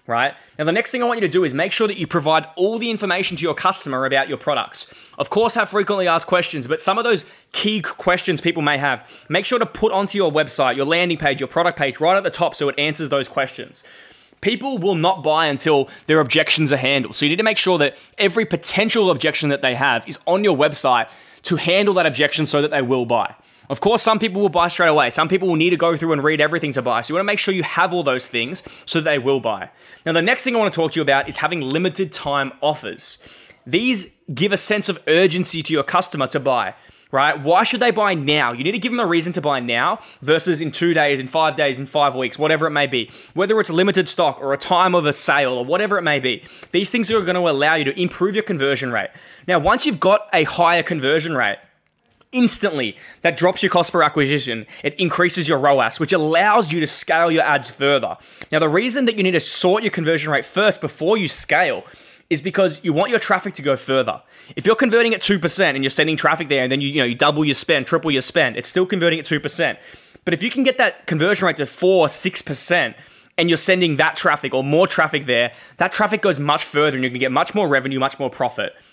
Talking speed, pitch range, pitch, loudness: 250 wpm, 145-190 Hz, 165 Hz, -18 LUFS